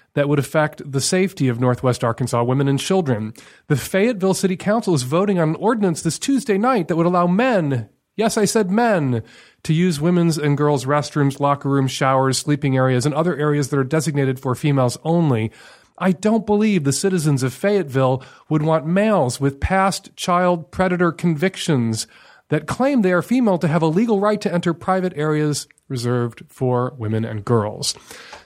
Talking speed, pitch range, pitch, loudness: 180 wpm, 135-190 Hz, 155 Hz, -19 LUFS